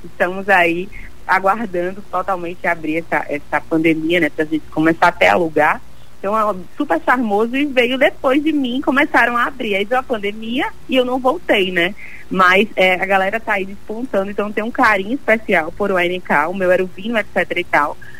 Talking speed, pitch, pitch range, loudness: 190 wpm, 195 Hz, 175-240 Hz, -17 LUFS